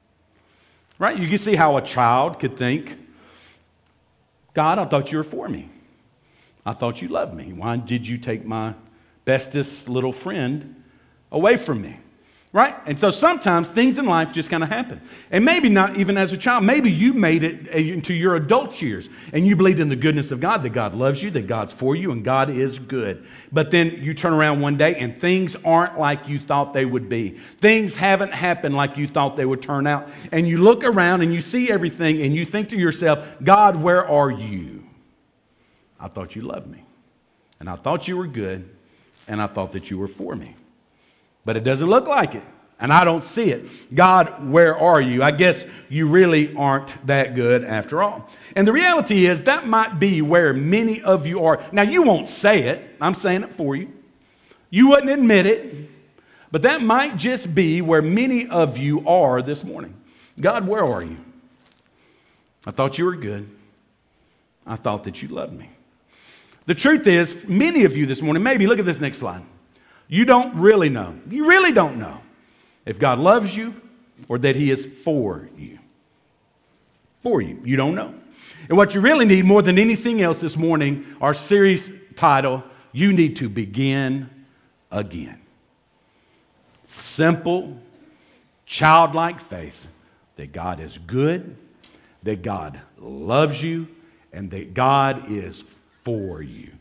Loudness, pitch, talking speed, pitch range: -19 LUFS, 155 Hz, 180 wpm, 130-190 Hz